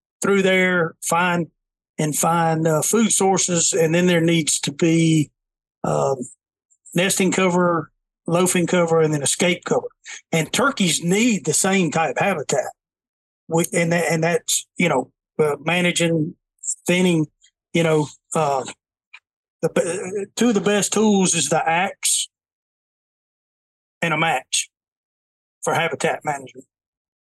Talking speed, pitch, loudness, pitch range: 130 wpm, 170 Hz, -19 LUFS, 155-185 Hz